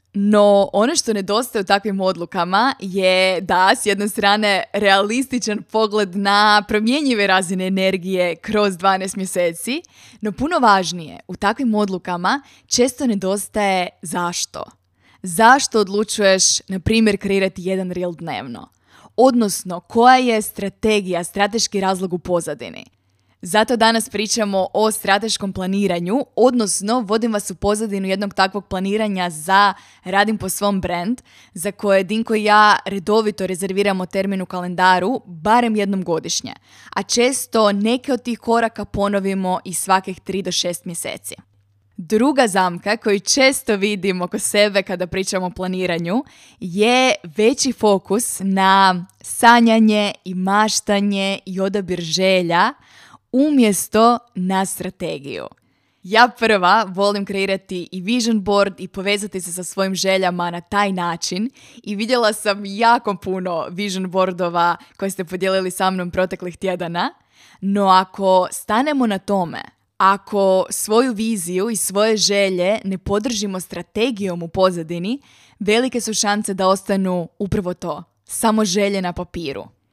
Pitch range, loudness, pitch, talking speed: 185-215 Hz, -18 LUFS, 200 Hz, 130 wpm